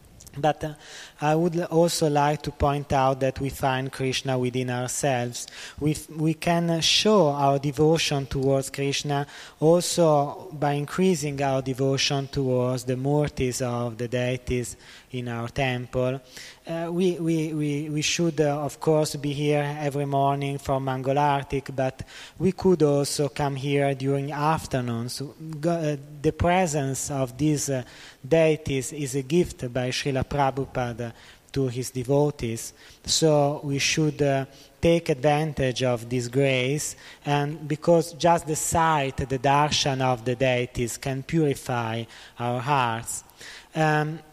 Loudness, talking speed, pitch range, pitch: -25 LUFS, 140 wpm, 130-150 Hz, 140 Hz